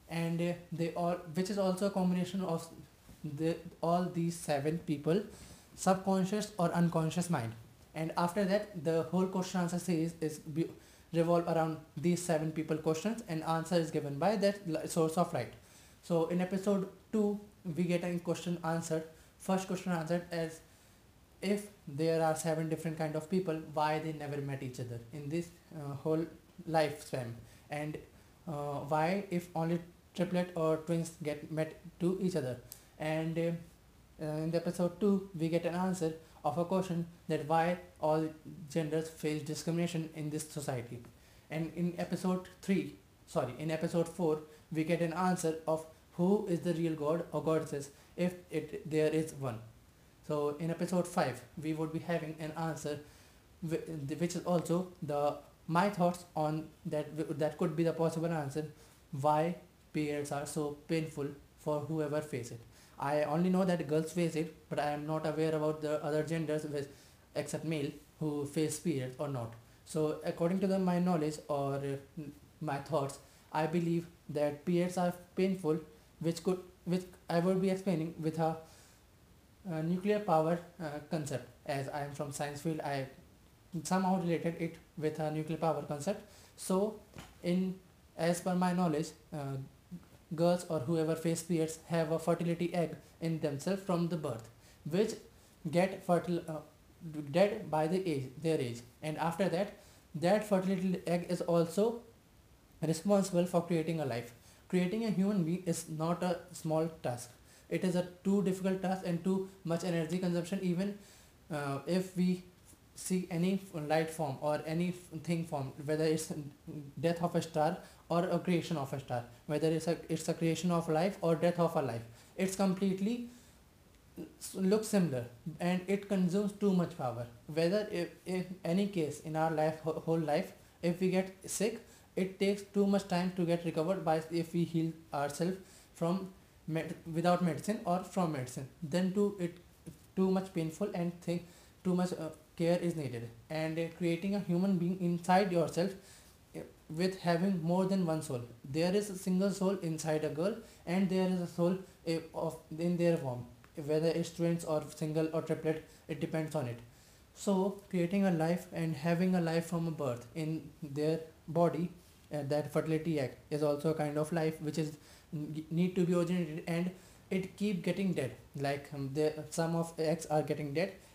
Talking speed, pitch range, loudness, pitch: 170 wpm, 155-175 Hz, -35 LUFS, 165 Hz